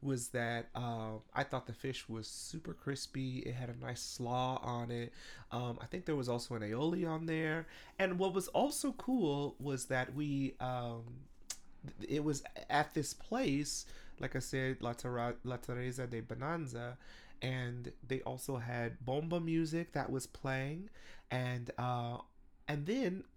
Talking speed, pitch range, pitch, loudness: 165 wpm, 120-150 Hz, 130 Hz, -39 LUFS